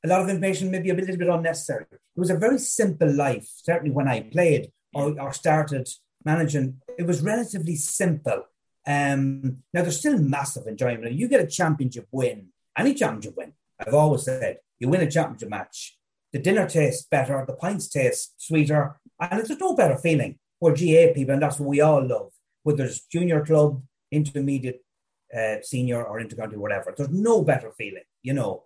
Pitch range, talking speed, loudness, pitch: 135-175 Hz, 185 wpm, -24 LUFS, 150 Hz